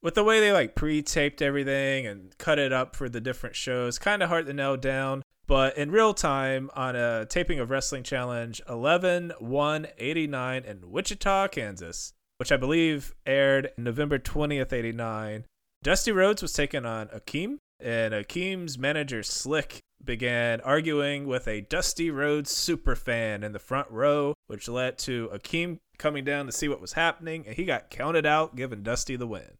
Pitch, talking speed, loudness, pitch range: 135 Hz, 170 wpm, -27 LUFS, 120-155 Hz